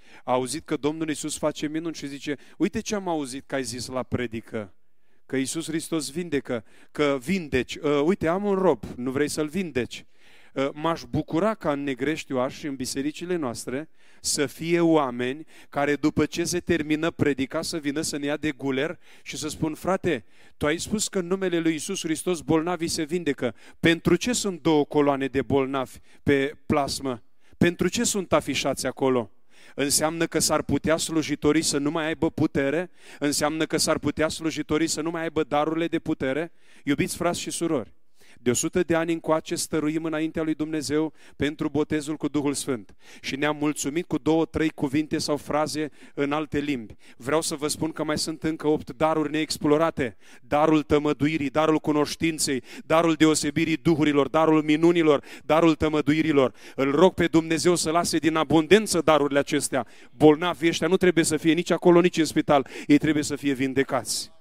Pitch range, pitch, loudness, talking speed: 145-165 Hz, 155 Hz, -25 LUFS, 175 wpm